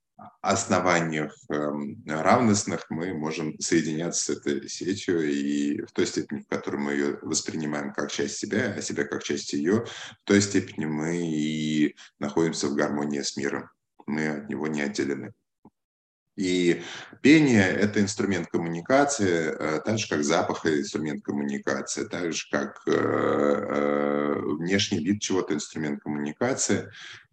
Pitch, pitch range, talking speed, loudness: 75 Hz, 75-90 Hz, 130 wpm, -26 LUFS